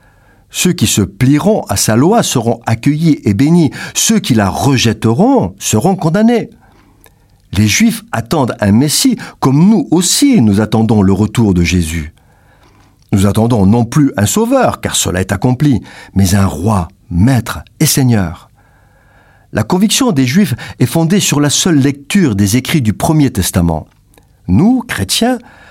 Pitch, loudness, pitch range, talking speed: 120 Hz, -11 LUFS, 100-160 Hz, 150 wpm